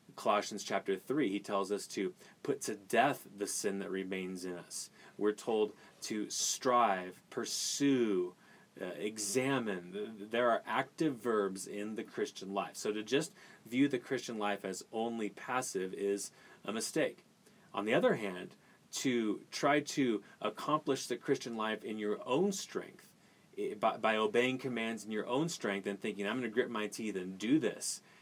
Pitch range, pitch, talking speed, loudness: 100-130 Hz, 110 Hz, 165 wpm, -36 LUFS